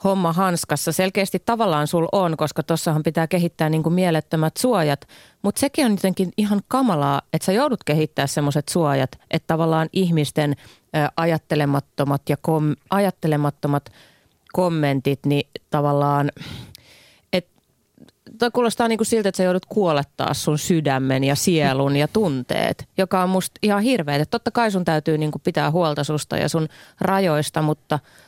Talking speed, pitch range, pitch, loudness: 140 wpm, 150-190 Hz, 160 Hz, -21 LUFS